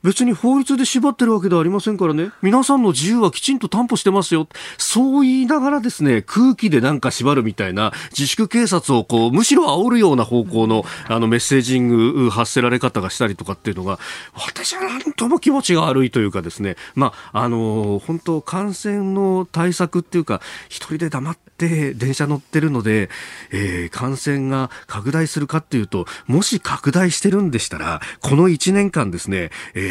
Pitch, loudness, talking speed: 155 Hz, -18 LUFS, 385 characters per minute